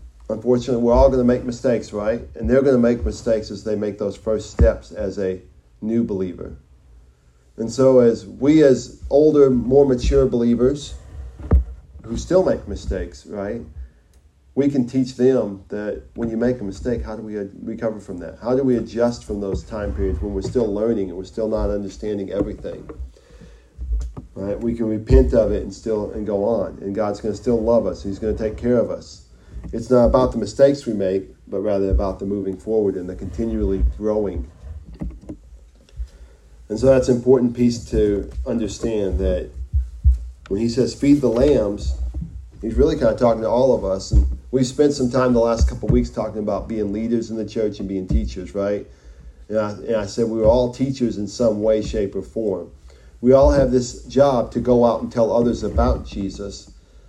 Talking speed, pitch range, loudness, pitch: 195 wpm, 95-120 Hz, -20 LUFS, 105 Hz